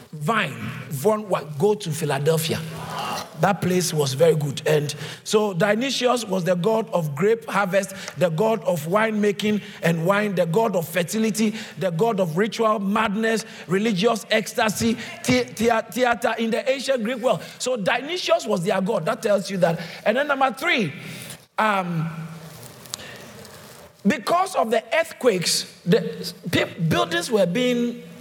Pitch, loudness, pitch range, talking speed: 210 Hz, -22 LUFS, 175-225 Hz, 145 wpm